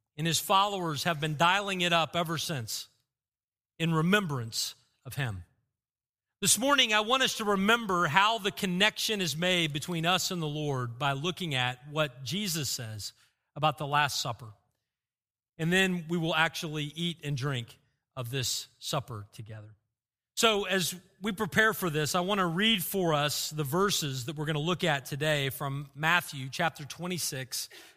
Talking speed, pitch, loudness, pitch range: 165 wpm, 155 Hz, -29 LUFS, 135-180 Hz